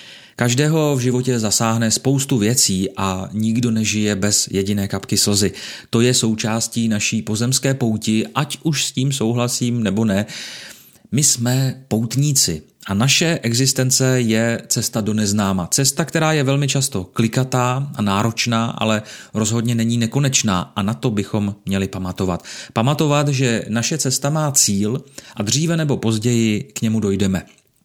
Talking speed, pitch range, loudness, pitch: 145 wpm, 105-130 Hz, -18 LUFS, 115 Hz